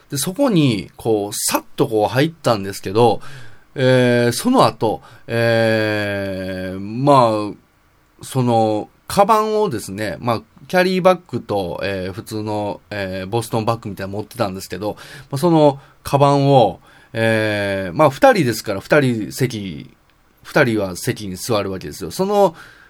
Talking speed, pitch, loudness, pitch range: 285 characters per minute, 115 Hz, -18 LUFS, 100-140 Hz